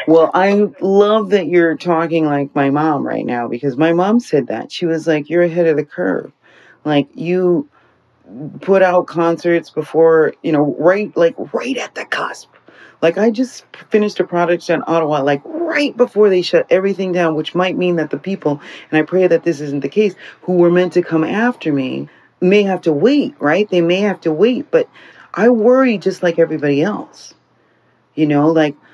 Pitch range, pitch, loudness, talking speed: 155-195 Hz, 175 Hz, -15 LUFS, 195 wpm